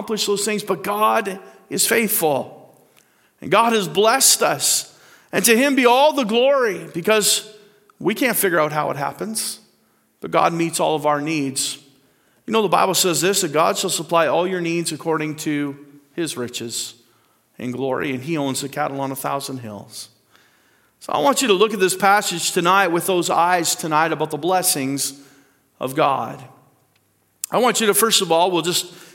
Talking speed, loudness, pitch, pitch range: 185 wpm, -18 LUFS, 170 Hz, 140-200 Hz